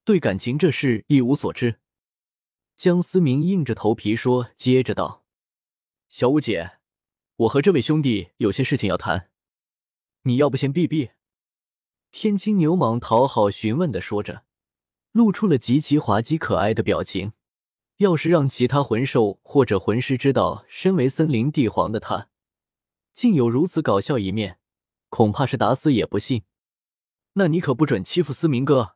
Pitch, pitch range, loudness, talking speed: 125 Hz, 100-155 Hz, -21 LUFS, 230 characters per minute